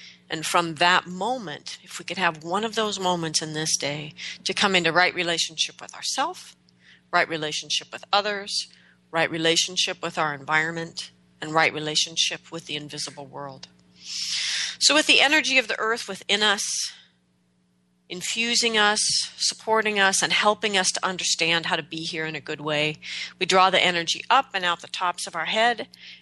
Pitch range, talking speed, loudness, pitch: 150-190 Hz, 175 wpm, -23 LUFS, 165 Hz